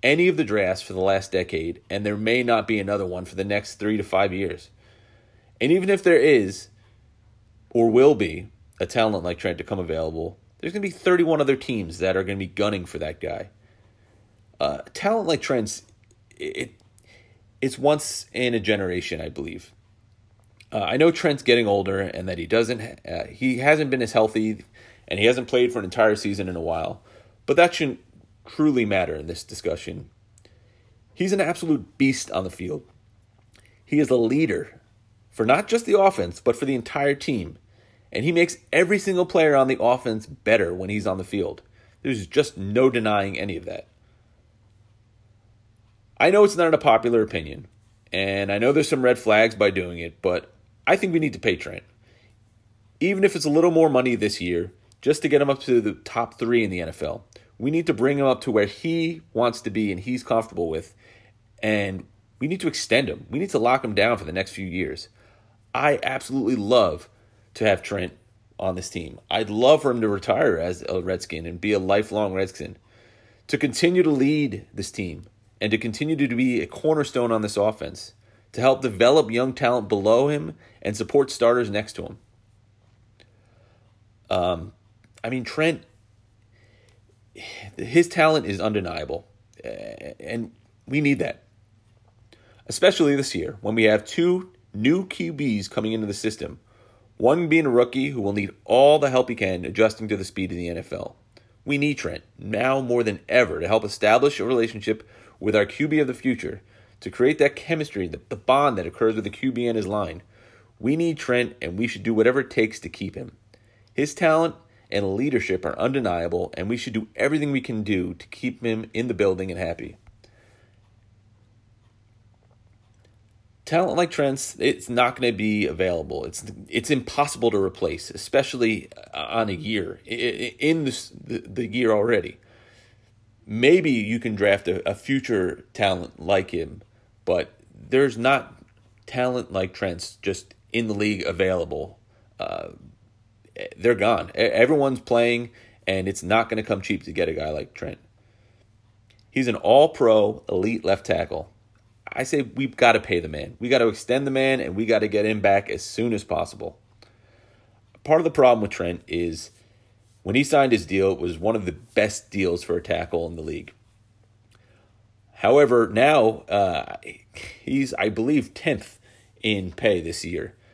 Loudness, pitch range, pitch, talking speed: -23 LUFS, 105-125 Hz, 110 Hz, 180 wpm